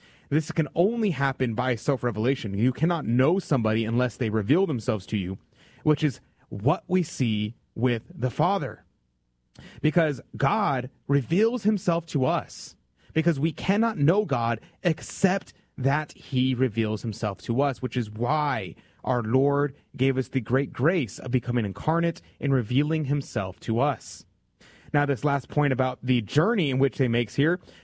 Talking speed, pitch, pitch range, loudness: 155 wpm, 135 Hz, 120-155 Hz, -26 LUFS